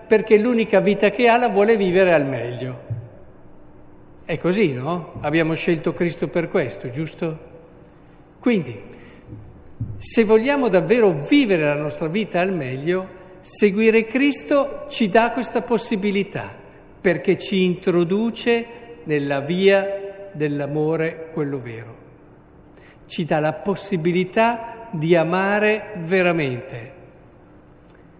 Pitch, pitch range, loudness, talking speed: 180 Hz, 150-215 Hz, -20 LUFS, 105 wpm